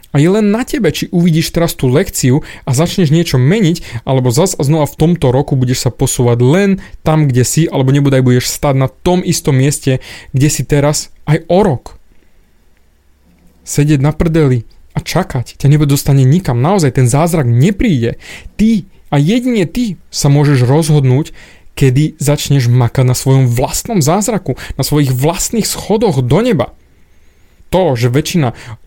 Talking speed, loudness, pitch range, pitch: 165 wpm, -12 LUFS, 125-165 Hz, 145 Hz